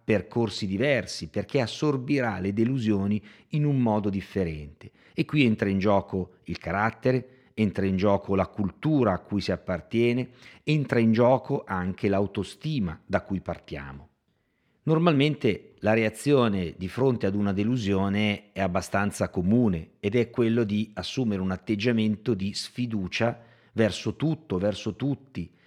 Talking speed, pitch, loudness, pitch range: 135 wpm, 105 Hz, -26 LUFS, 95-120 Hz